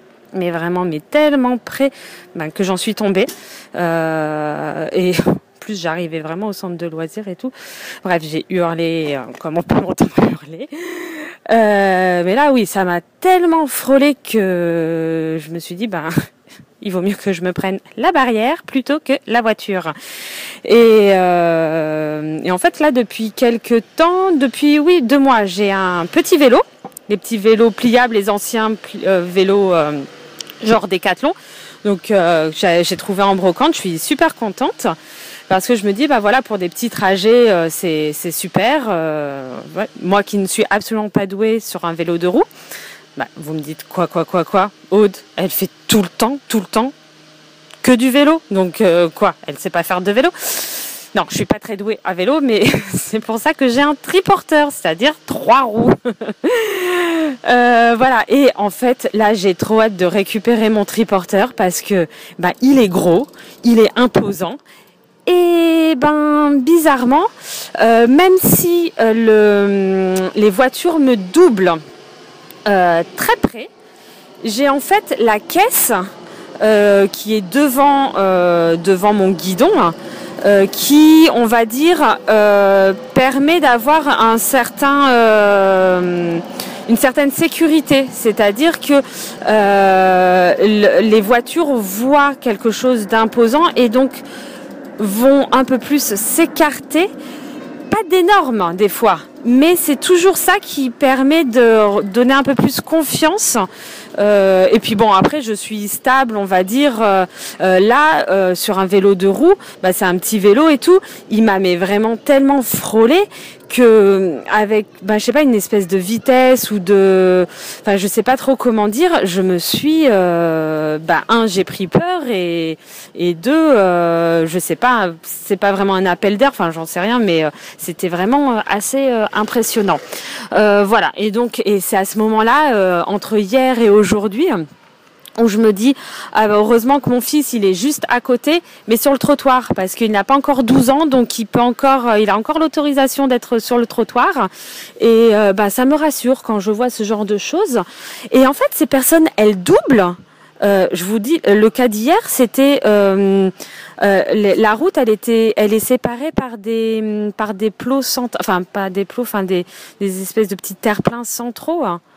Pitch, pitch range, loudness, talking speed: 220 Hz, 190-270 Hz, -14 LUFS, 170 wpm